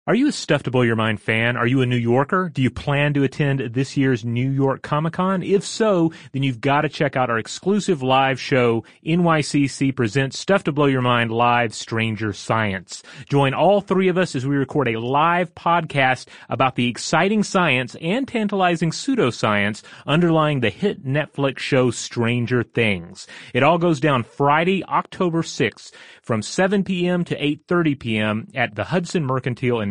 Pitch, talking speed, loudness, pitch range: 140 Hz, 185 wpm, -20 LUFS, 120-170 Hz